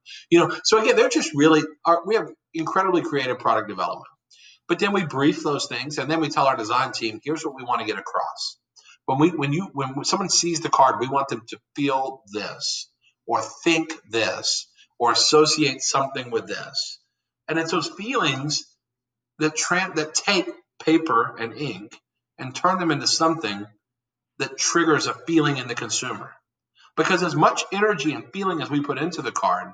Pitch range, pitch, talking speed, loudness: 130-170 Hz, 155 Hz, 185 wpm, -22 LUFS